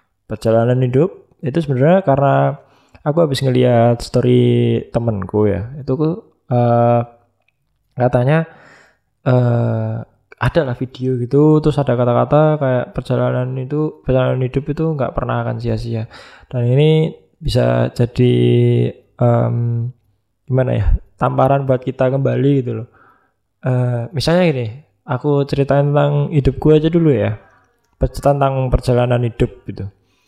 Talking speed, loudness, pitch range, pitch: 125 wpm, -16 LUFS, 120-140 Hz, 125 Hz